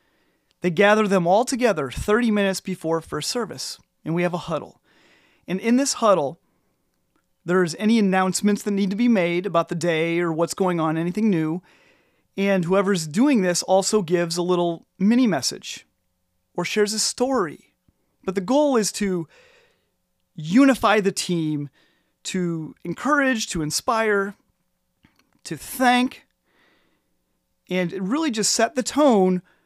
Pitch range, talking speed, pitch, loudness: 175-220 Hz, 140 wpm, 190 Hz, -21 LUFS